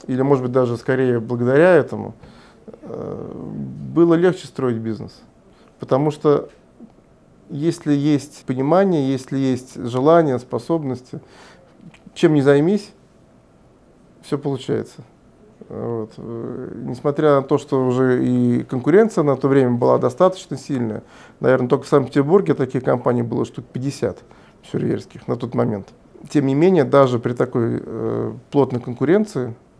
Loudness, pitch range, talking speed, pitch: -19 LUFS, 125-145 Hz, 125 wpm, 135 Hz